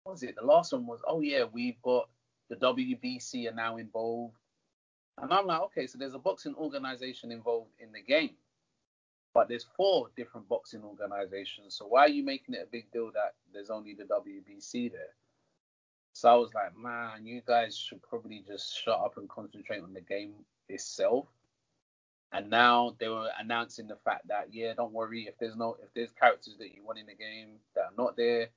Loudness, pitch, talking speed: -32 LUFS, 115 Hz, 200 wpm